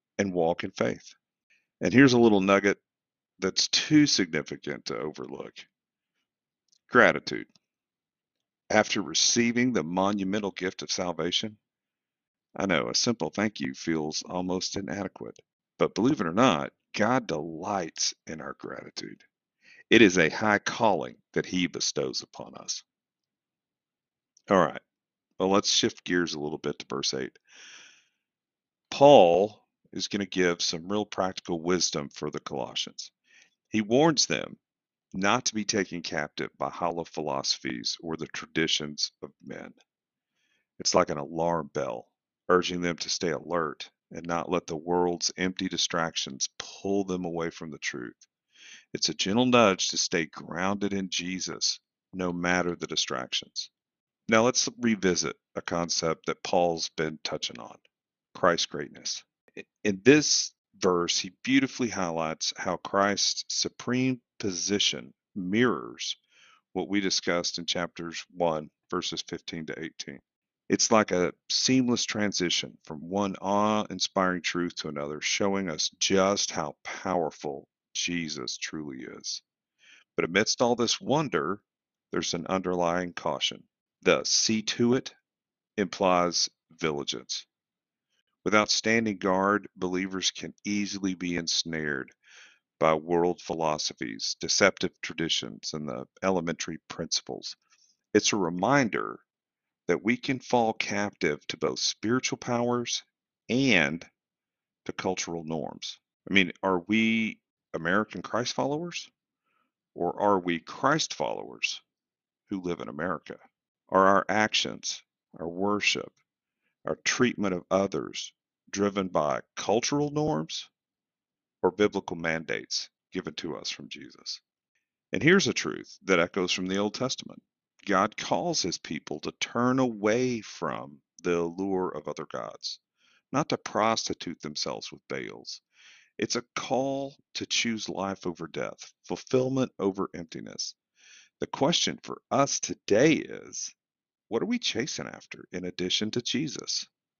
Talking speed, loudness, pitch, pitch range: 130 wpm, -27 LUFS, 95 Hz, 85-110 Hz